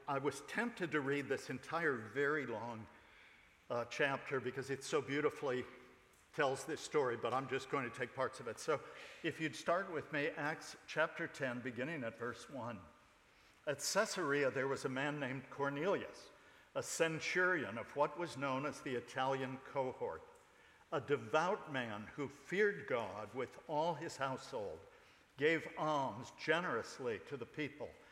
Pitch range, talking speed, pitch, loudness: 130-170 Hz, 160 wpm, 140 Hz, -40 LUFS